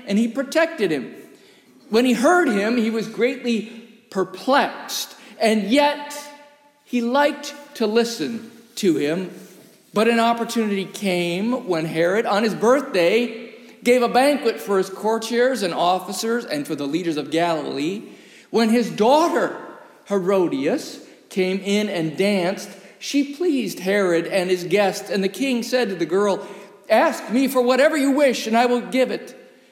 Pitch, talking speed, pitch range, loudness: 230 Hz, 150 wpm, 195-260 Hz, -20 LUFS